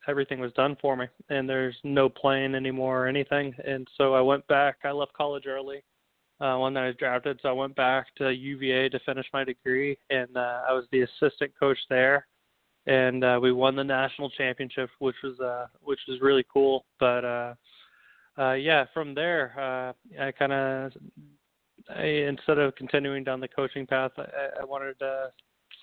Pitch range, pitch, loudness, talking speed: 130-140 Hz, 135 Hz, -27 LUFS, 190 wpm